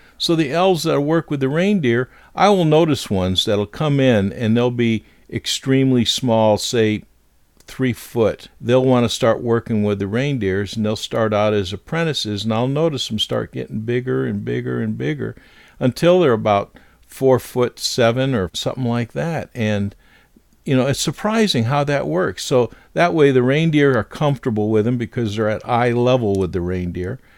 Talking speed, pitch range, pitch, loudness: 180 wpm, 105-135 Hz, 120 Hz, -18 LUFS